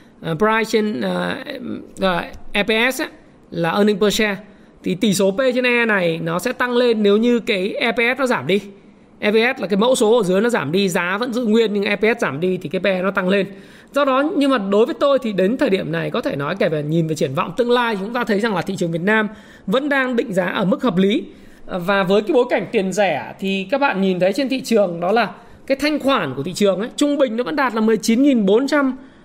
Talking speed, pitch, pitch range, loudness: 255 wpm, 220 Hz, 195-245 Hz, -18 LUFS